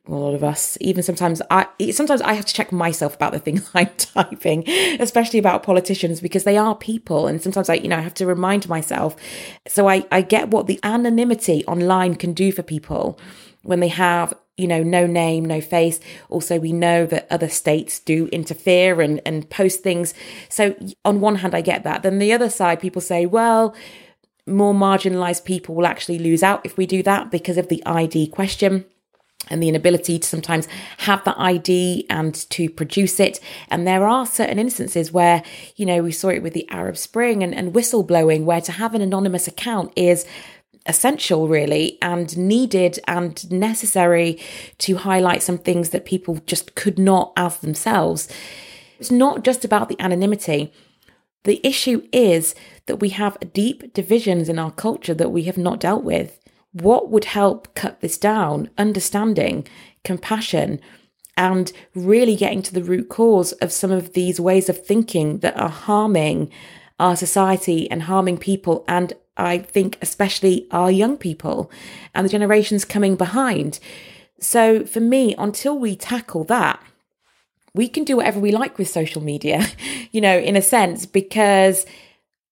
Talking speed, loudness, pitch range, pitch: 175 wpm, -19 LUFS, 170-205 Hz, 185 Hz